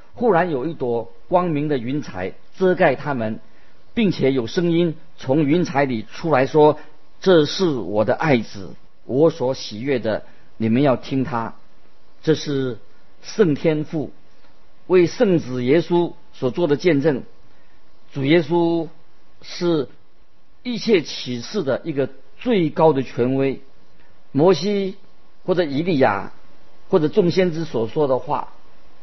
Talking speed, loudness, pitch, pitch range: 185 characters per minute, -20 LUFS, 155 Hz, 135-175 Hz